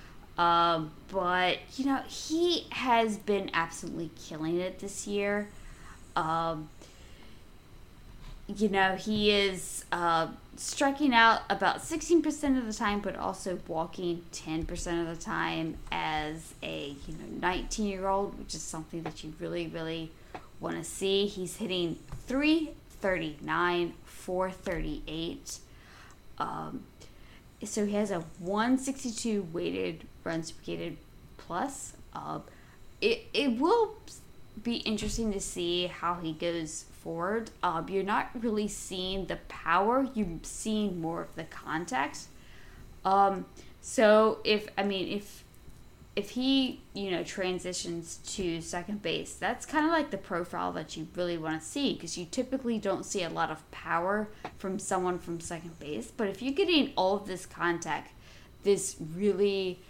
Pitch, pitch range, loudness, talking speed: 190 Hz, 170-215 Hz, -31 LUFS, 135 wpm